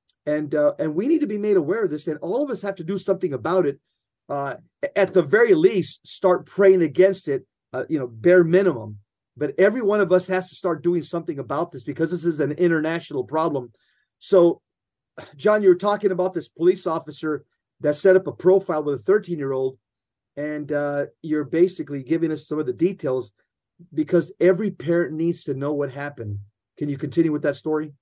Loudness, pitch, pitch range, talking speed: -22 LUFS, 165 Hz, 145-185 Hz, 205 wpm